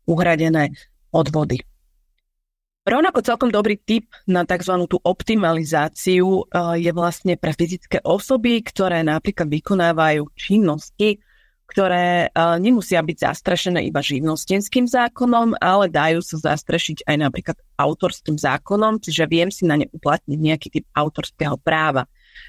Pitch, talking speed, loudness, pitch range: 170 Hz, 115 wpm, -19 LUFS, 155-195 Hz